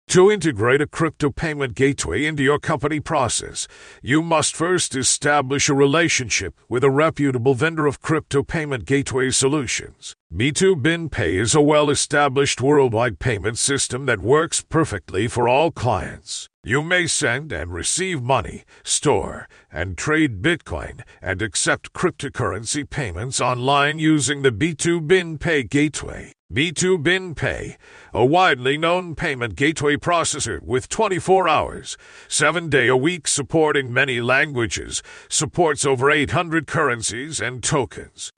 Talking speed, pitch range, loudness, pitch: 125 wpm, 130-160 Hz, -20 LUFS, 145 Hz